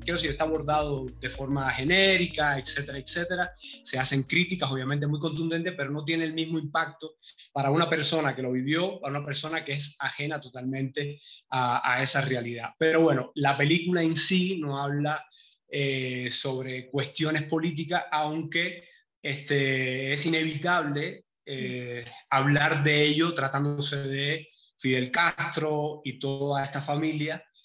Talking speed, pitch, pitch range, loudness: 145 wpm, 150 Hz, 135-160 Hz, -27 LUFS